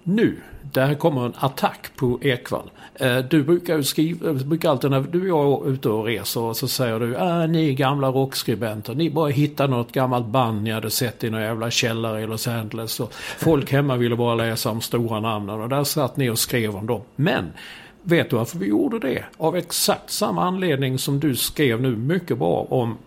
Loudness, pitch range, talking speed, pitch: -22 LUFS, 115-150 Hz, 210 wpm, 130 Hz